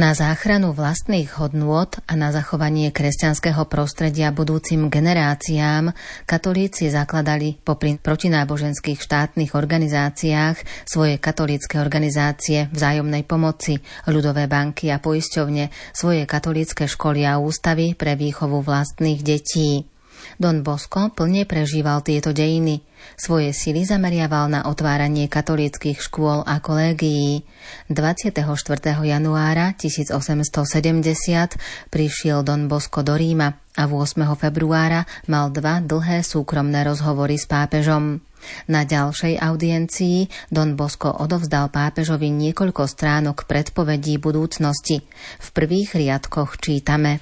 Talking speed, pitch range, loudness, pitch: 105 wpm, 145-160 Hz, -20 LUFS, 150 Hz